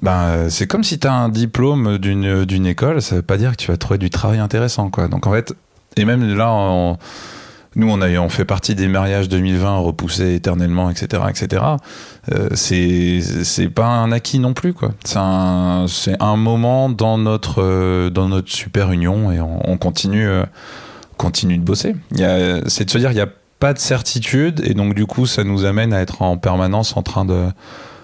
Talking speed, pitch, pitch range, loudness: 210 wpm, 100 Hz, 90-115 Hz, -17 LUFS